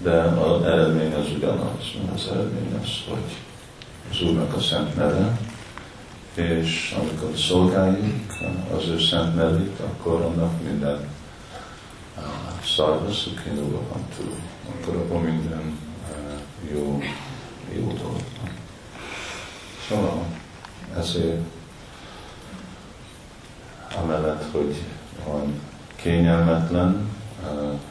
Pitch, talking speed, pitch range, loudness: 85 Hz, 85 wpm, 75-90 Hz, -24 LUFS